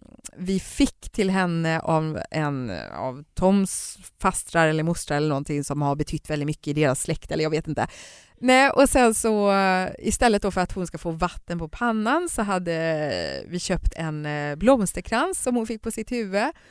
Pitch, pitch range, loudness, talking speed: 180 Hz, 155-220 Hz, -24 LUFS, 185 wpm